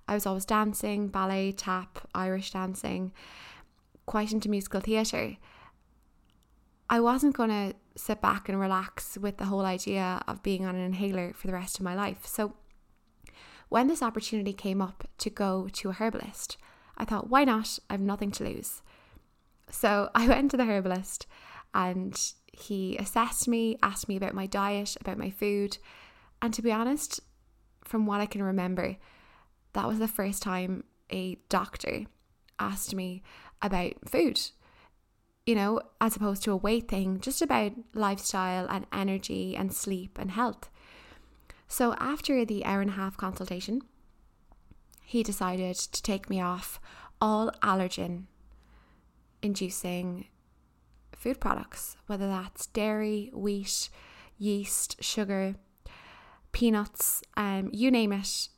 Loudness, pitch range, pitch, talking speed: -31 LUFS, 190-220 Hz, 200 Hz, 145 wpm